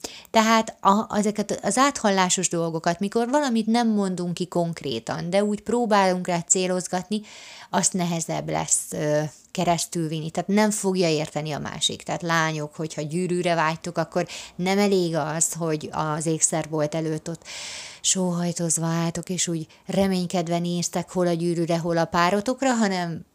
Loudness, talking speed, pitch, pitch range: -24 LUFS, 145 wpm, 175 Hz, 165-195 Hz